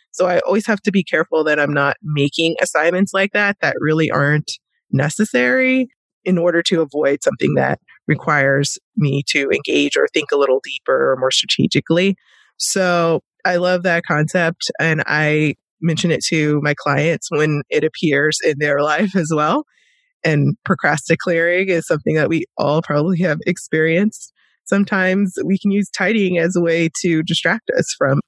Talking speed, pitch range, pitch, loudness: 165 wpm, 150-185 Hz, 165 Hz, -17 LUFS